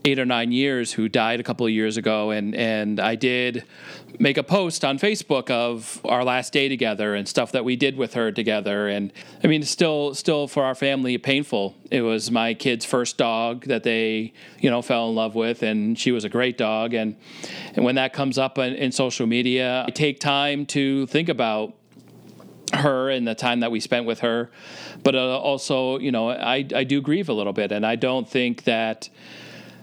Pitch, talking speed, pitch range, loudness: 125 Hz, 215 wpm, 115-135 Hz, -22 LUFS